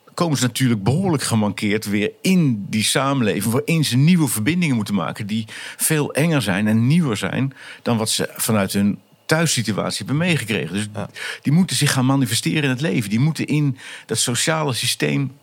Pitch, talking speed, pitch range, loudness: 130 Hz, 175 wpm, 110-150 Hz, -19 LUFS